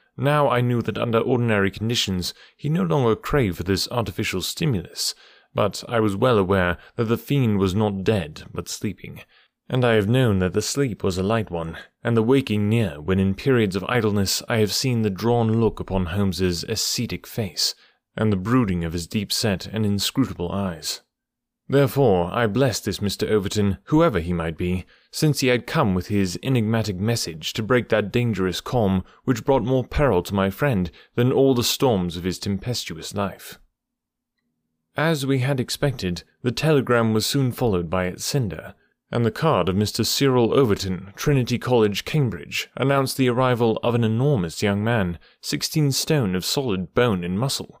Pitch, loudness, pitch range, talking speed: 110 Hz, -22 LUFS, 95-125 Hz, 180 wpm